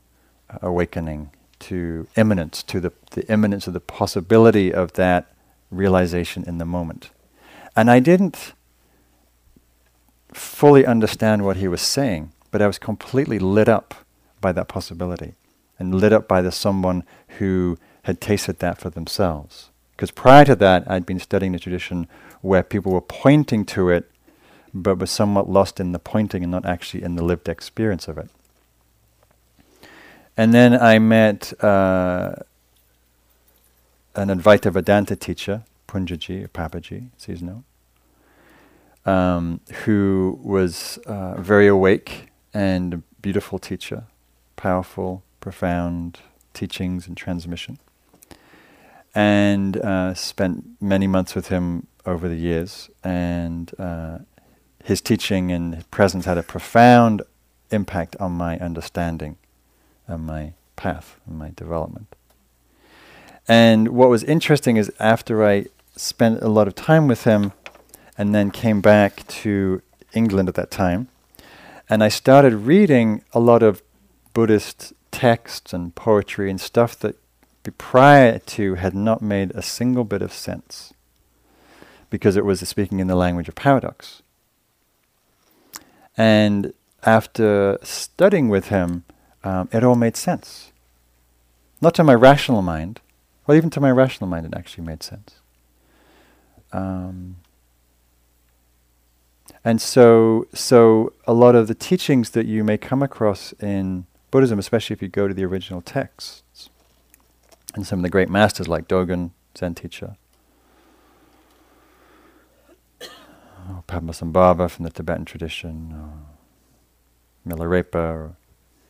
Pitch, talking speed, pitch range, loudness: 95 Hz, 130 wpm, 85-105 Hz, -19 LUFS